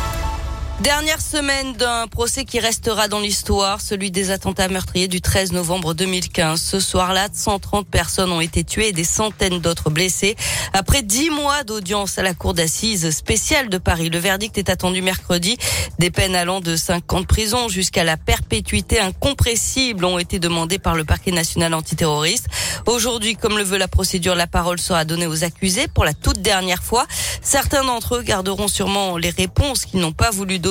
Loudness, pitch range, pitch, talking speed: -18 LUFS, 175-210 Hz, 190 Hz, 180 wpm